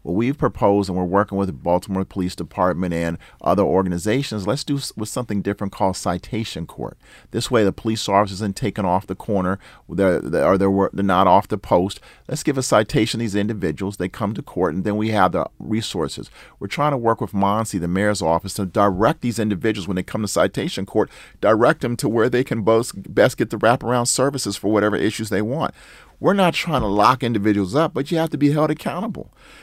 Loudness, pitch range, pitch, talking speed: -20 LUFS, 95-120 Hz, 105 Hz, 215 wpm